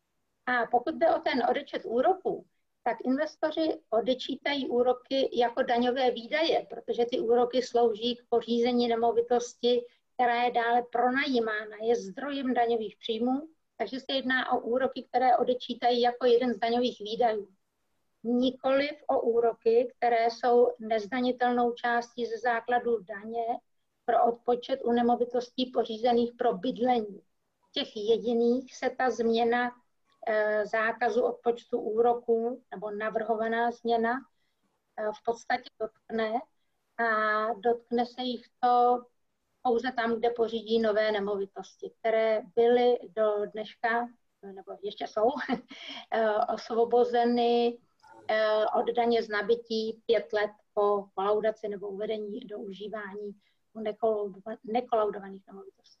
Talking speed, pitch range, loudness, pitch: 115 wpm, 225-245 Hz, -29 LUFS, 235 Hz